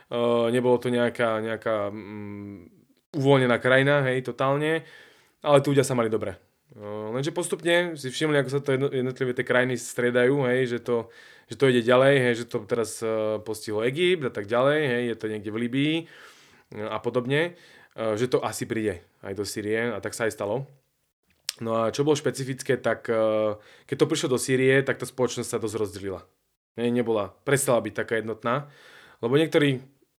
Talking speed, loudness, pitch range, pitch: 185 wpm, -25 LUFS, 110-140 Hz, 125 Hz